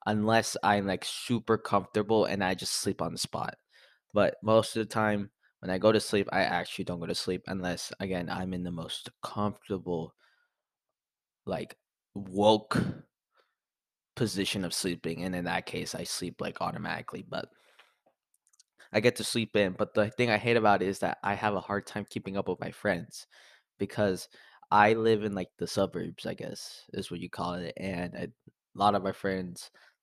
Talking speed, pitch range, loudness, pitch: 190 wpm, 90-105 Hz, -30 LUFS, 100 Hz